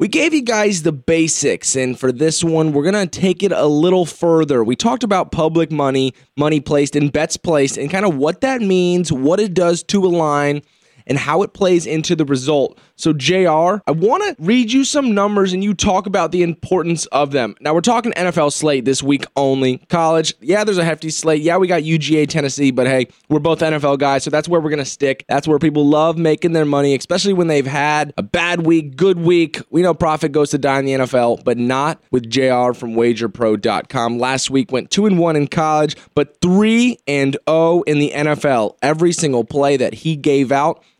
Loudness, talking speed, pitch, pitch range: -16 LUFS, 215 wpm, 155 Hz, 140-175 Hz